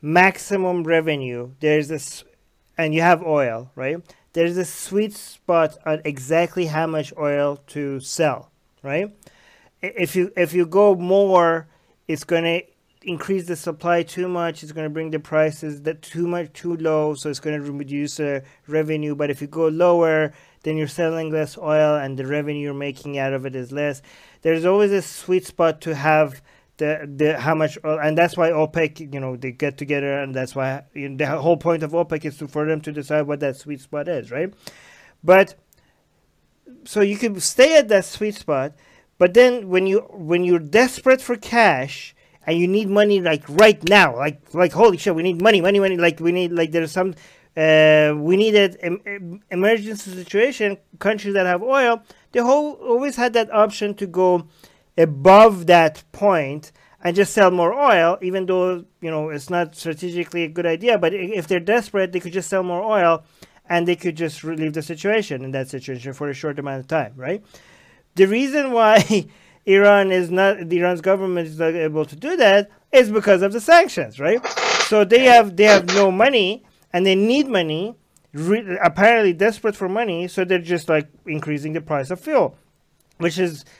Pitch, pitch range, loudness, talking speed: 170 Hz, 155-195 Hz, -19 LUFS, 190 wpm